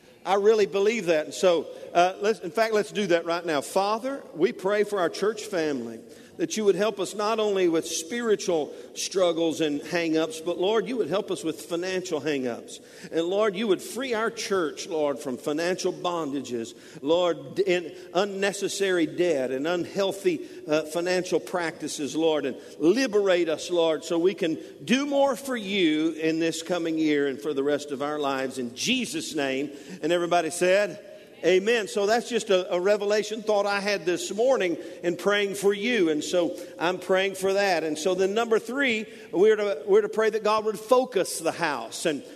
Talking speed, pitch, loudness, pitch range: 185 wpm, 185 Hz, -26 LUFS, 165-215 Hz